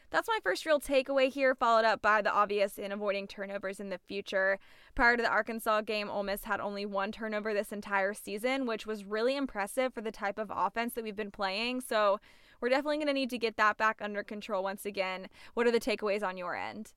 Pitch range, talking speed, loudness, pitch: 200-235 Hz, 225 wpm, -32 LUFS, 215 Hz